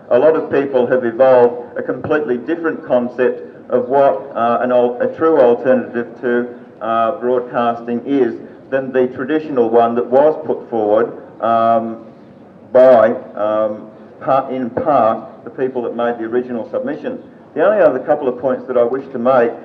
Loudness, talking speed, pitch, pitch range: -15 LUFS, 165 wpm, 125 Hz, 120-130 Hz